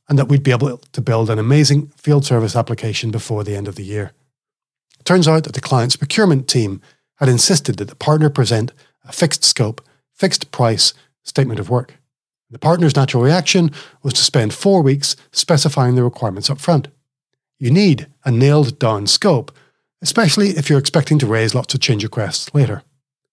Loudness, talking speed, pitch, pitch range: -15 LUFS, 185 wpm, 135 Hz, 120-150 Hz